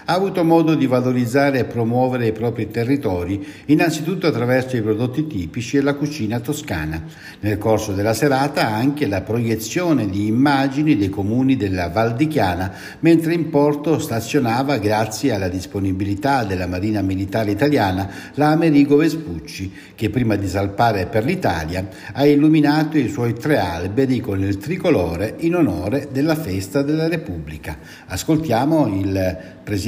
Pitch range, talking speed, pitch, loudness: 100-145 Hz, 140 wpm, 120 Hz, -19 LUFS